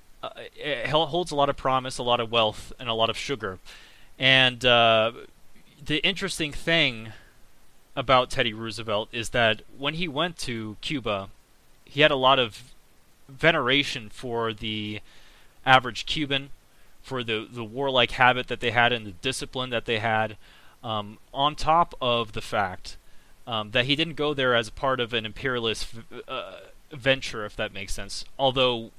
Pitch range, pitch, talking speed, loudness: 110-140 Hz, 125 Hz, 165 wpm, -25 LUFS